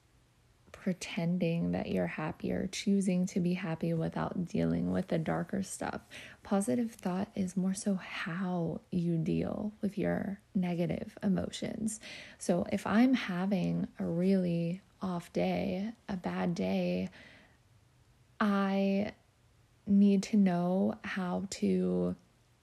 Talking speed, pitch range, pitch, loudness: 115 wpm, 165-200 Hz, 185 Hz, -33 LUFS